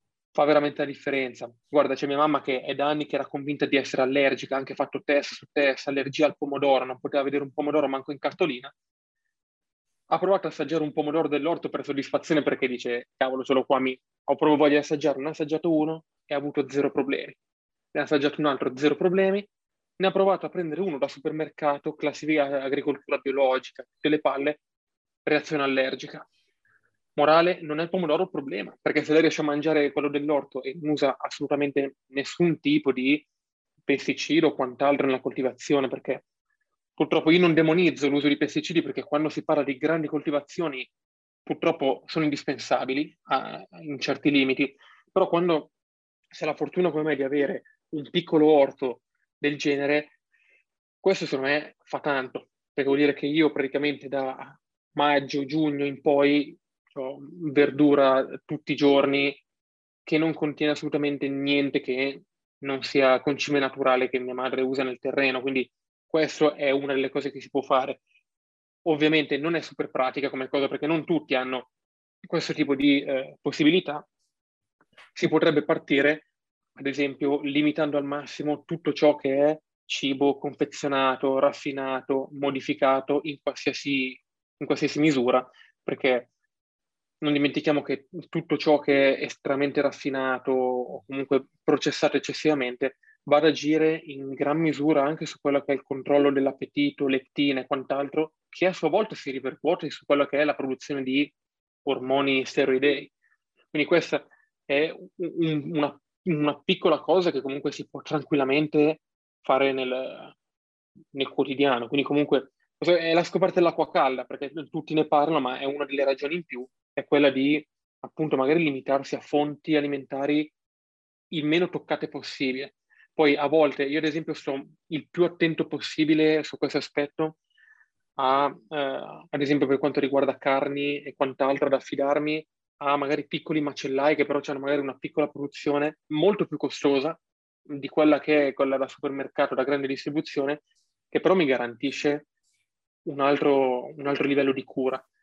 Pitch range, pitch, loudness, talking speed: 135-155 Hz, 145 Hz, -25 LUFS, 160 wpm